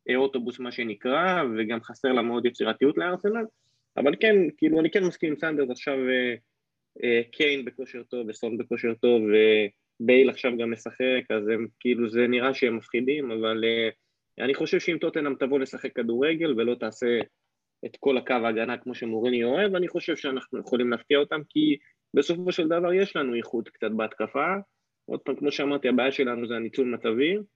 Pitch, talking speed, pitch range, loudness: 125 Hz, 170 wpm, 115-145 Hz, -26 LUFS